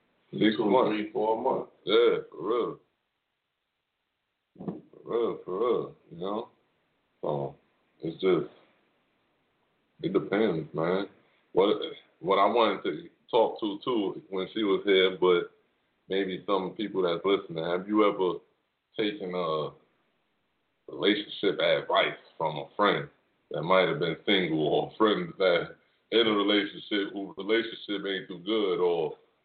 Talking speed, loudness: 130 wpm, -28 LUFS